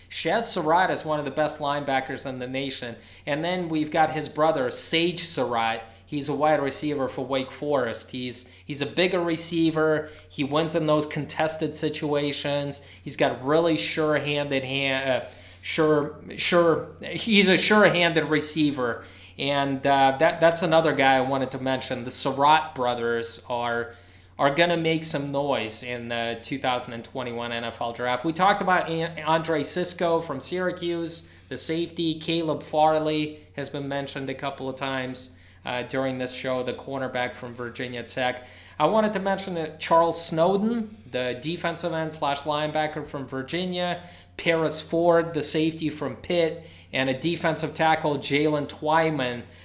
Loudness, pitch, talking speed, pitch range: -25 LUFS, 145 Hz, 155 wpm, 130-165 Hz